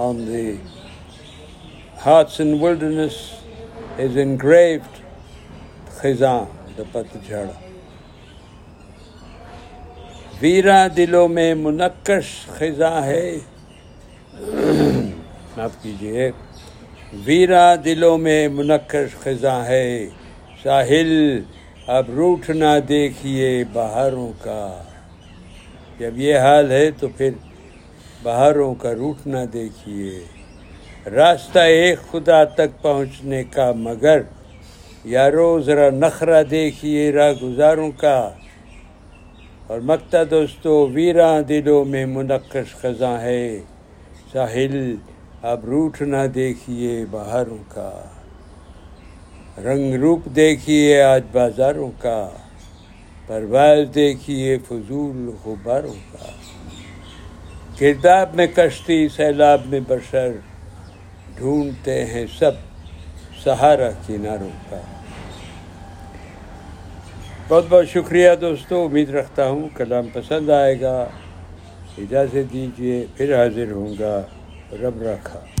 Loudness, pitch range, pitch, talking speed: -17 LUFS, 90-145 Hz, 125 Hz, 85 wpm